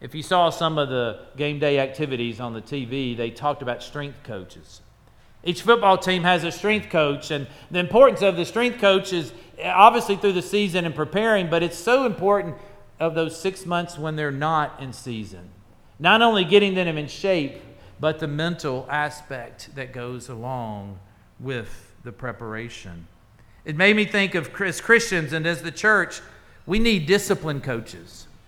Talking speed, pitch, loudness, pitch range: 175 wpm, 150 Hz, -21 LUFS, 120-185 Hz